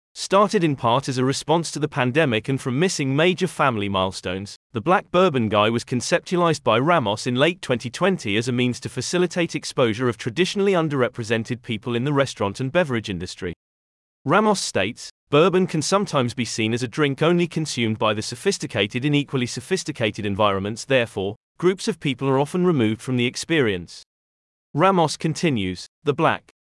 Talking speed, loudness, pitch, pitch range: 170 wpm, -22 LUFS, 130 Hz, 115-165 Hz